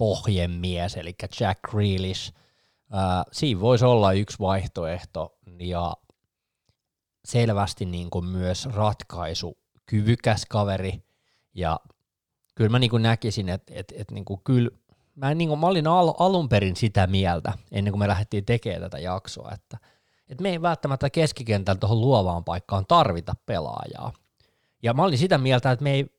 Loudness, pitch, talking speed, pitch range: -24 LUFS, 105 Hz, 150 wpm, 95-125 Hz